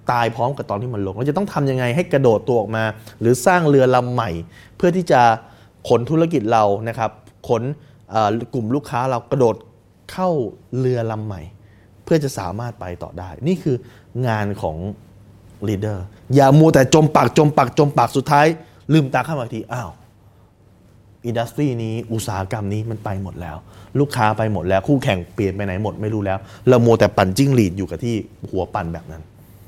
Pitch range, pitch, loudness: 100-130 Hz, 110 Hz, -19 LUFS